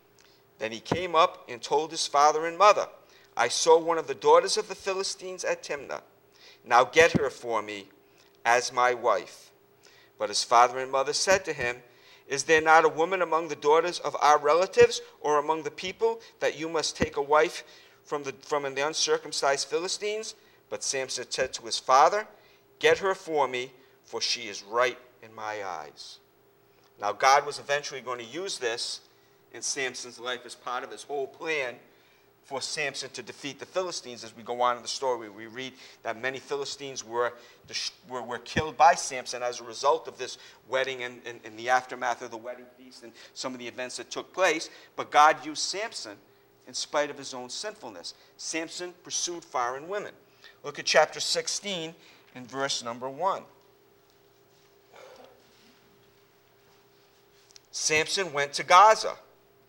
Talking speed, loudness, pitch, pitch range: 170 wpm, -27 LUFS, 145 Hz, 125-180 Hz